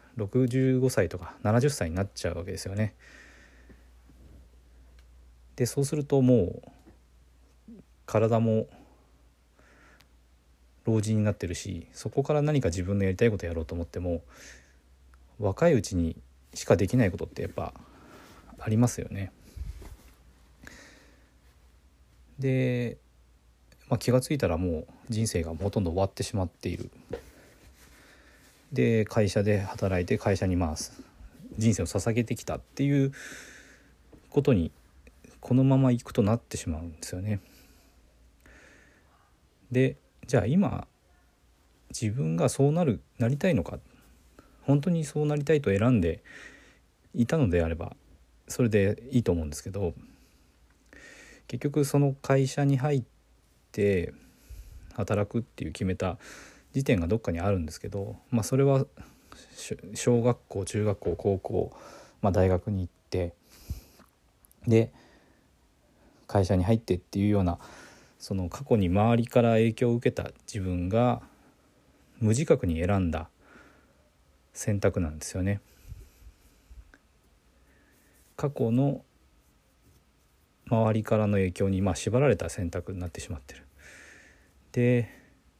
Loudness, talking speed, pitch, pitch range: -28 LUFS, 240 characters per minute, 95 Hz, 75-120 Hz